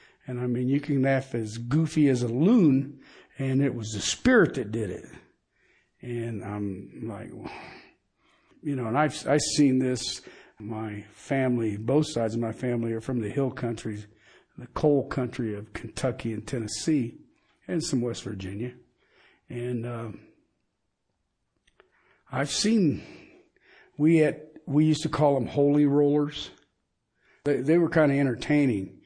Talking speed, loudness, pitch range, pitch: 145 wpm, -26 LUFS, 115-145 Hz, 130 Hz